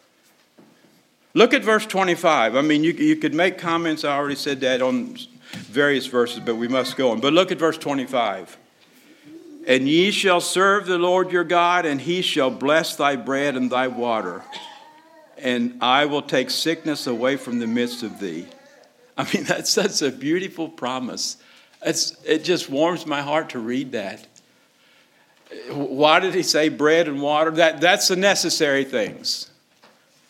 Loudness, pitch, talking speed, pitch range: -20 LUFS, 160 Hz, 165 wpm, 140-195 Hz